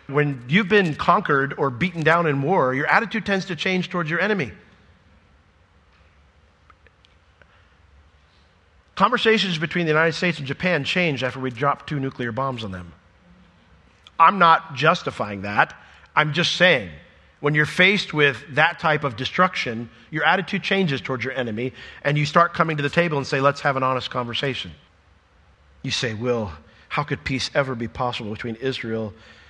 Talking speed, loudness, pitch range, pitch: 160 wpm, -21 LUFS, 100-165 Hz, 135 Hz